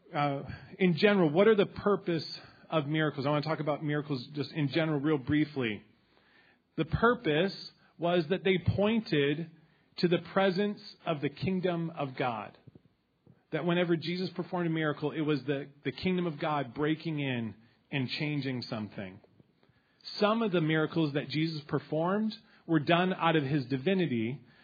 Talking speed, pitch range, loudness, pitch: 160 wpm, 145-180 Hz, -31 LUFS, 160 Hz